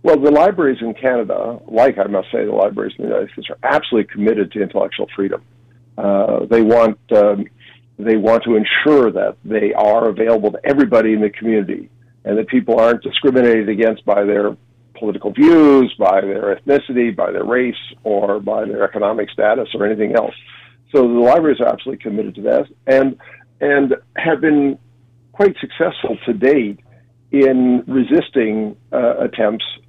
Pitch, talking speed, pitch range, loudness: 120 Hz, 165 wpm, 110-130 Hz, -15 LUFS